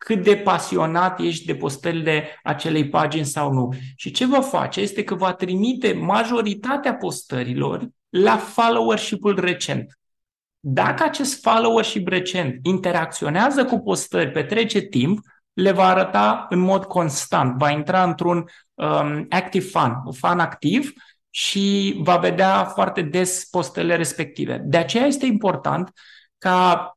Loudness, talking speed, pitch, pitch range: -20 LUFS, 135 wpm, 185 Hz, 165-210 Hz